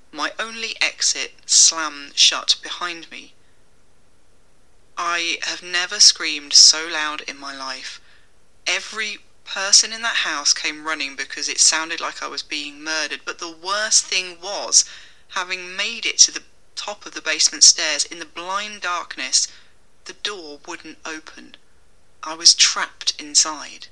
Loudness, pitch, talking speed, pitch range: -17 LUFS, 160 Hz, 145 wpm, 145-185 Hz